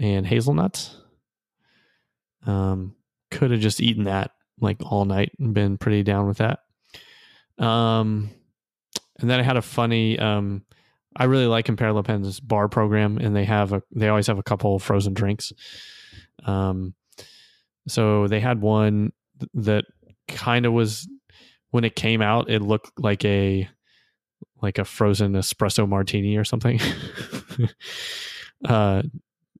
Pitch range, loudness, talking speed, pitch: 100-115 Hz, -23 LUFS, 140 wpm, 105 Hz